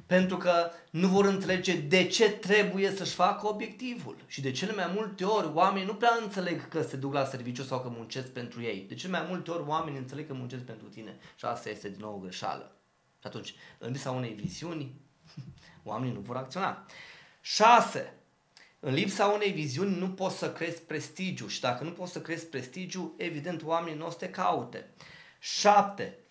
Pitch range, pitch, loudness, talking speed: 135-190 Hz, 170 Hz, -30 LUFS, 185 wpm